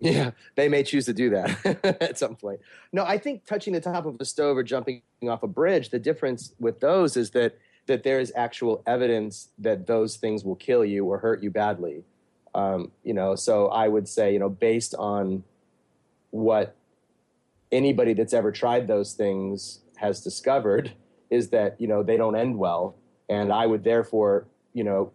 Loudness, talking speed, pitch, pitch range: -25 LUFS, 190 wpm, 115 Hz, 105-130 Hz